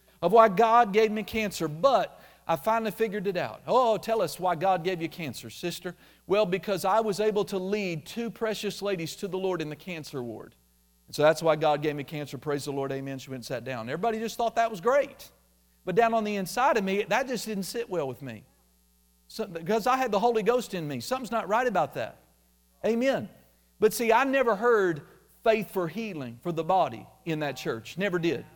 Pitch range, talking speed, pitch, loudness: 150-220 Hz, 225 wpm, 190 Hz, -27 LUFS